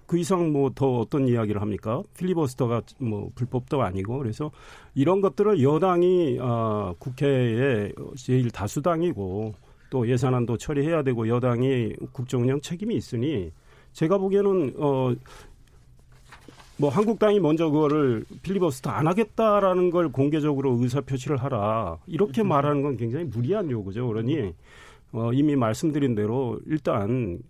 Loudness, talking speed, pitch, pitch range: -25 LUFS, 315 characters per minute, 135 Hz, 115-160 Hz